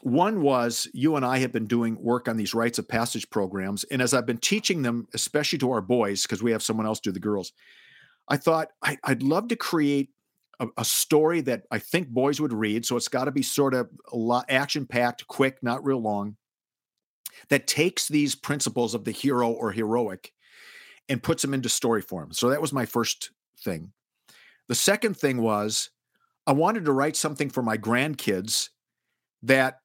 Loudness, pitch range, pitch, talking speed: -25 LUFS, 115-145 Hz, 125 Hz, 195 wpm